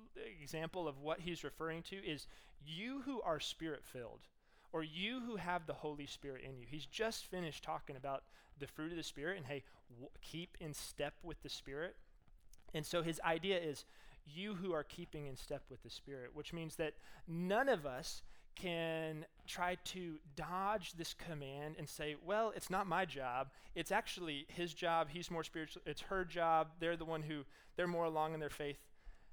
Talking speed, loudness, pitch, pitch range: 190 wpm, -43 LUFS, 160 Hz, 145-175 Hz